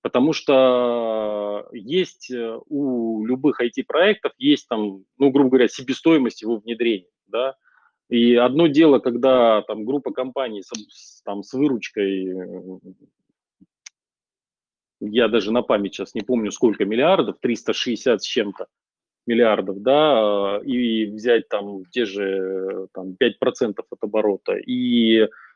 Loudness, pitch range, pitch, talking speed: -20 LUFS, 105-130 Hz, 115 Hz, 120 wpm